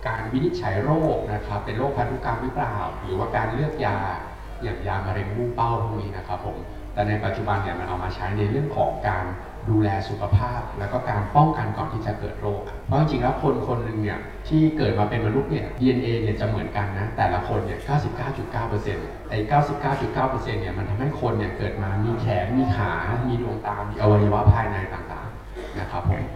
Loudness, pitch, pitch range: -25 LUFS, 105 Hz, 100-125 Hz